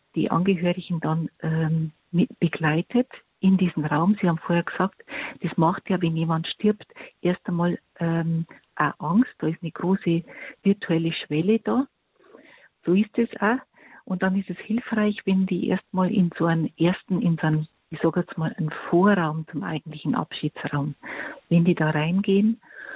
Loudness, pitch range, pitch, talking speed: -24 LUFS, 160-195 Hz, 175 Hz, 165 wpm